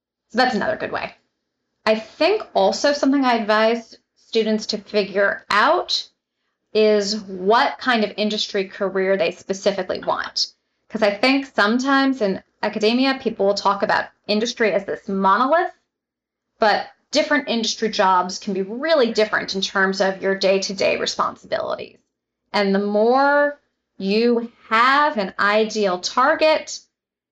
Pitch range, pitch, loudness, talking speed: 200-255 Hz, 215 Hz, -20 LUFS, 135 wpm